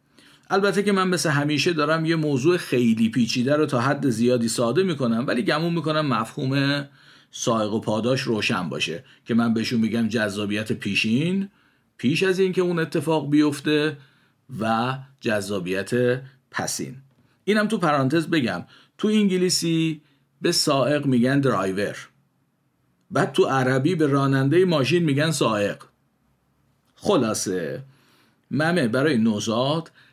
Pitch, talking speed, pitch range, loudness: 140 Hz, 125 wpm, 120-160 Hz, -22 LUFS